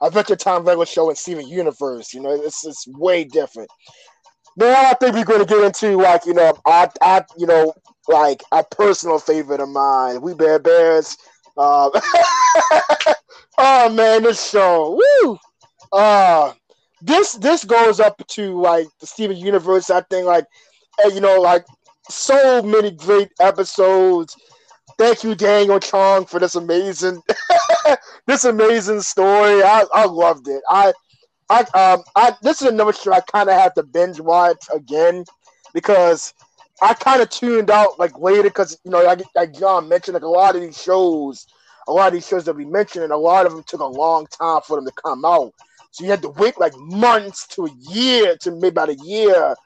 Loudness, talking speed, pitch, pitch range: -15 LUFS, 180 wpm, 190 Hz, 170-220 Hz